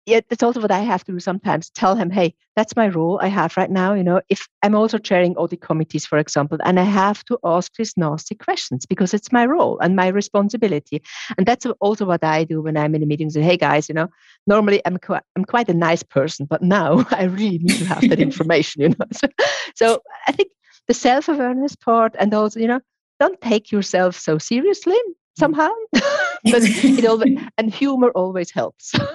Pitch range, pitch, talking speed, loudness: 175-235 Hz, 200 Hz, 215 wpm, -18 LUFS